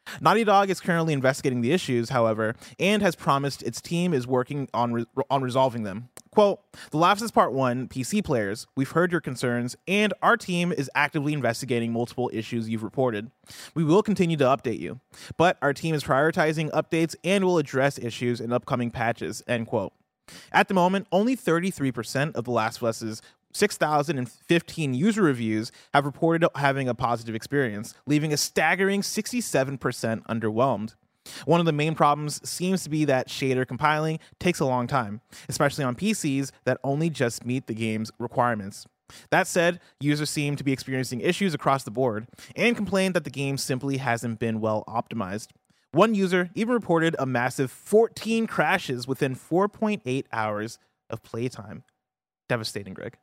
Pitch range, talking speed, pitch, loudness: 120-170 Hz, 165 wpm, 140 Hz, -25 LUFS